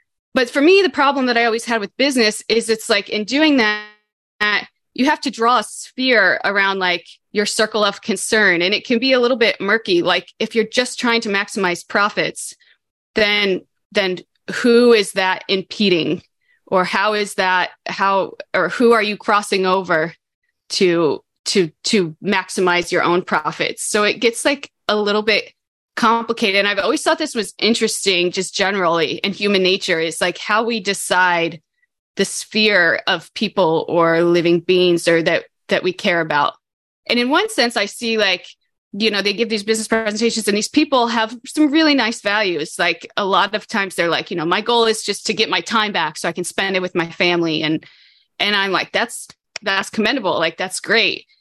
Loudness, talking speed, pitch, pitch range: -17 LUFS, 195 wpm, 205 Hz, 185-230 Hz